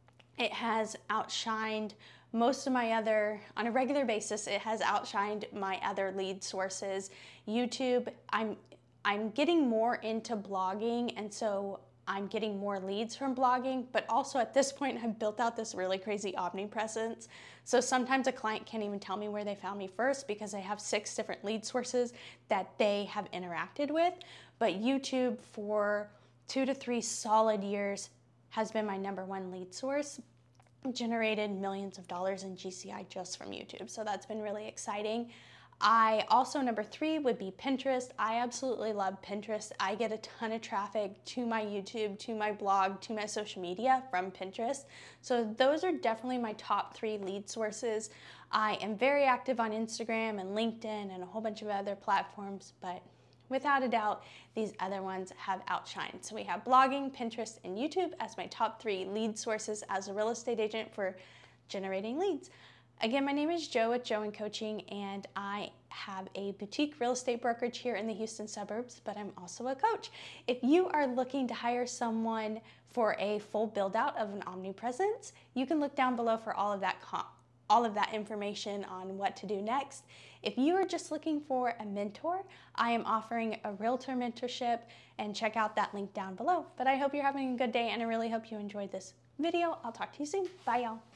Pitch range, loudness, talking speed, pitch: 200-245 Hz, -35 LUFS, 190 wpm, 220 Hz